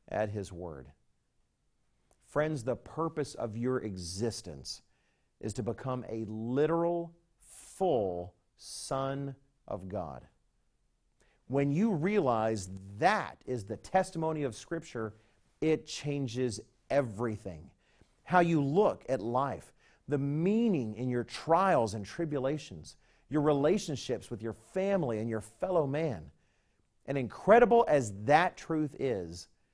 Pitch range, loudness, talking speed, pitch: 110-150 Hz, -32 LUFS, 115 wpm, 125 Hz